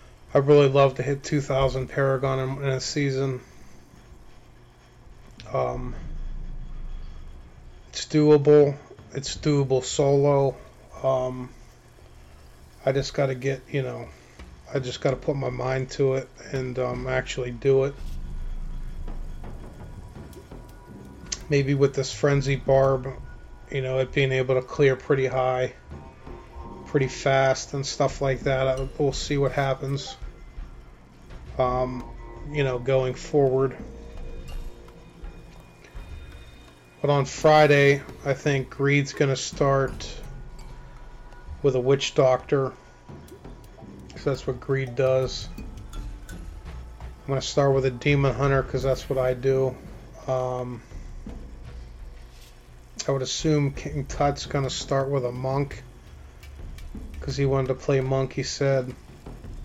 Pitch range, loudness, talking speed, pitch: 80-140 Hz, -24 LUFS, 120 wpm, 130 Hz